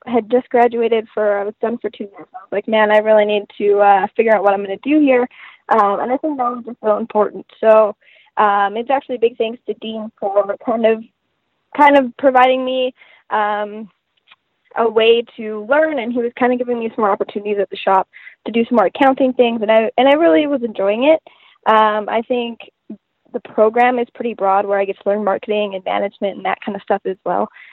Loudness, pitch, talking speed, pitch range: -16 LUFS, 225 Hz, 225 wpm, 210-250 Hz